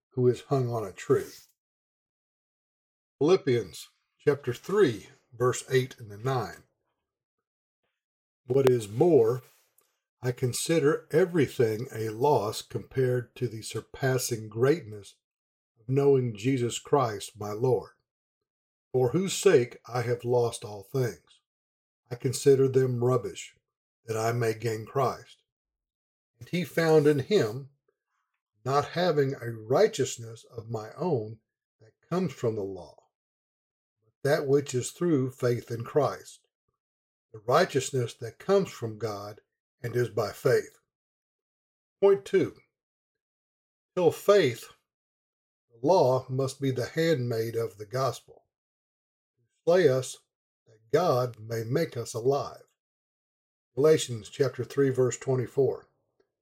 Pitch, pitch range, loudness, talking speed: 125 Hz, 115-140 Hz, -27 LUFS, 120 wpm